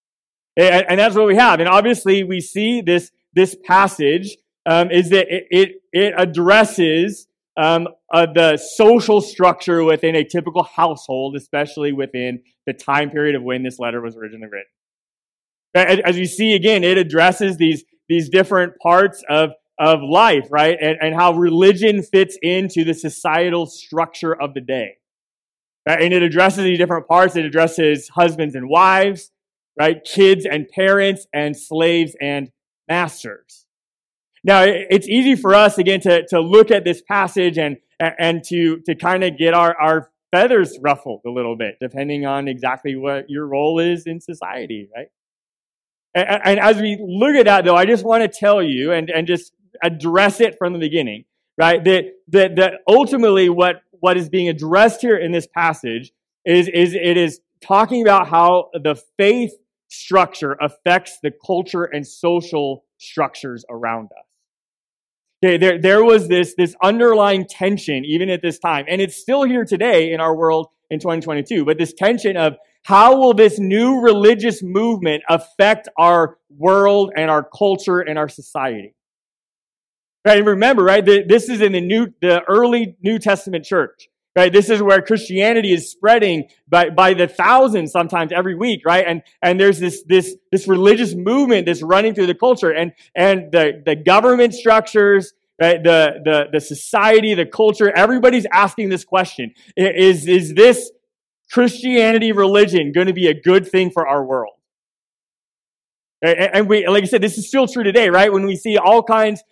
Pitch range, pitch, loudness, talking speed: 160-200 Hz, 180 Hz, -15 LUFS, 165 wpm